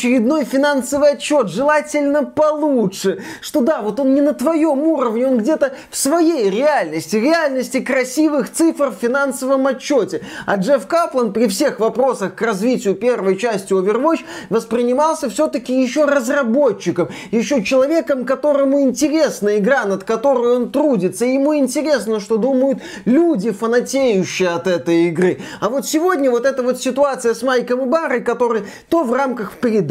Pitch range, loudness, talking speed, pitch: 230-290 Hz, -17 LUFS, 145 wpm, 260 Hz